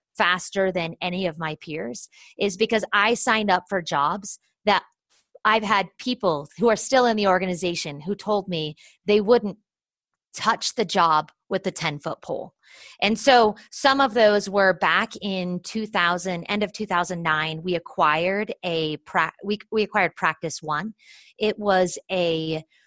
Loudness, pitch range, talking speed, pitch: -23 LUFS, 165-210 Hz, 150 wpm, 190 Hz